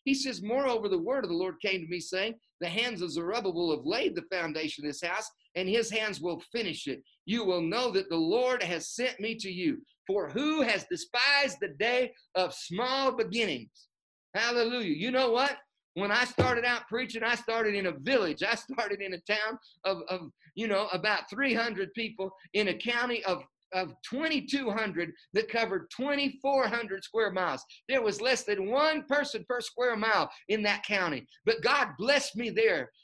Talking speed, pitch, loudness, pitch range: 185 wpm, 220 Hz, -30 LUFS, 190-250 Hz